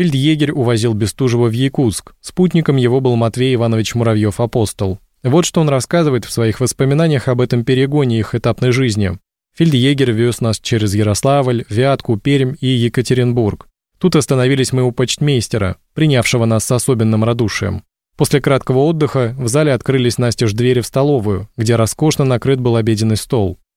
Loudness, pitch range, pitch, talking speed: -15 LUFS, 115-135 Hz, 125 Hz, 150 wpm